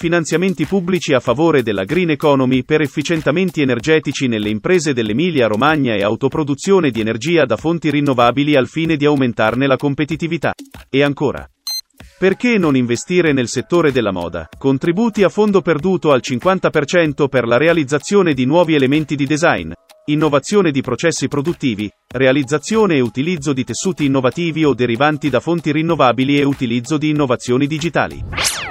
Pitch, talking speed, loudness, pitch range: 150 Hz, 145 wpm, -16 LUFS, 130-170 Hz